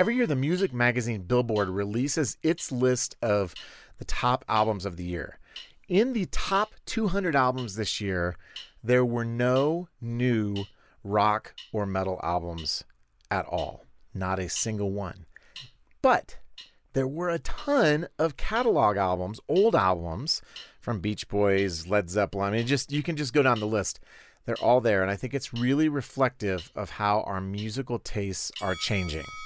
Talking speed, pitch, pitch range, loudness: 160 wpm, 110 Hz, 100-135 Hz, -27 LUFS